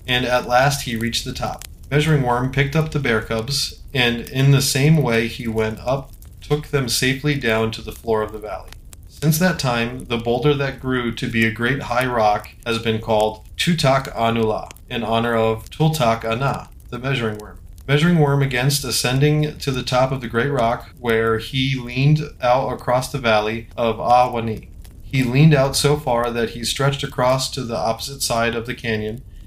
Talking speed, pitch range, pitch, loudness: 190 wpm, 115-140 Hz, 125 Hz, -19 LUFS